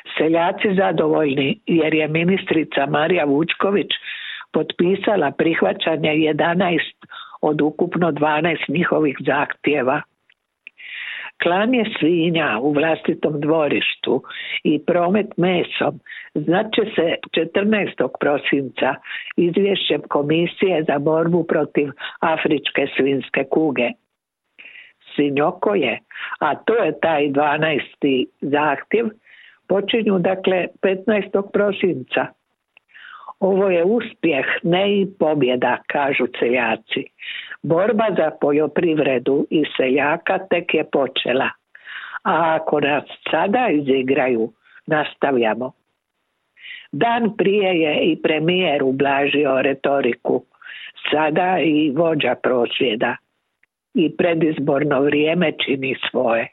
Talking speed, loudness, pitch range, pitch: 90 wpm, -19 LUFS, 145-195 Hz, 160 Hz